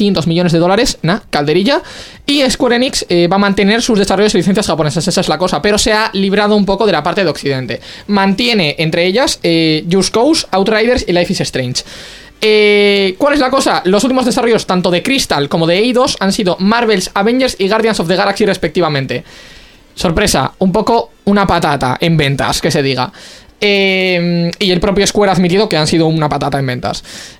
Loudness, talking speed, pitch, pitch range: -12 LUFS, 200 wpm, 195 Hz, 170-215 Hz